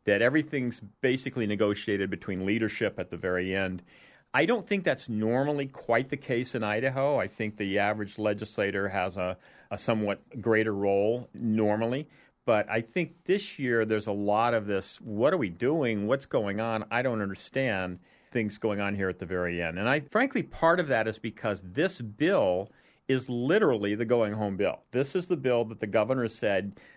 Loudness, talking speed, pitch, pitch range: -29 LUFS, 185 wpm, 110 Hz, 100-130 Hz